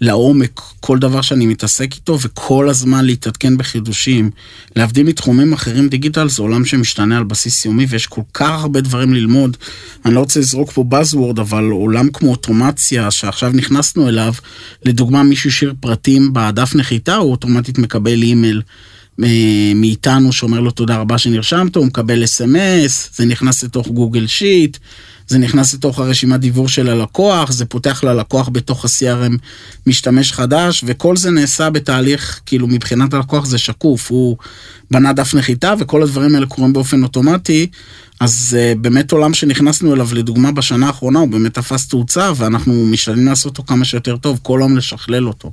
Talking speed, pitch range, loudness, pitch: 155 wpm, 115-140 Hz, -13 LUFS, 125 Hz